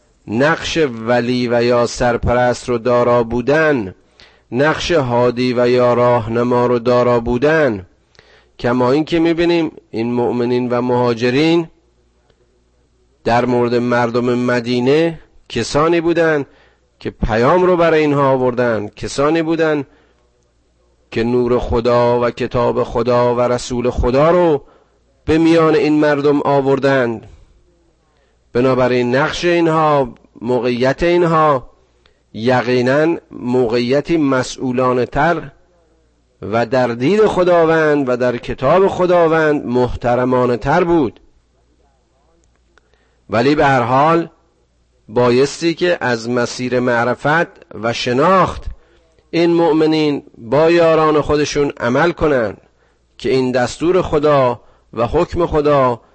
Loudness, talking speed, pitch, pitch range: -15 LUFS, 105 wpm, 125 Hz, 120-155 Hz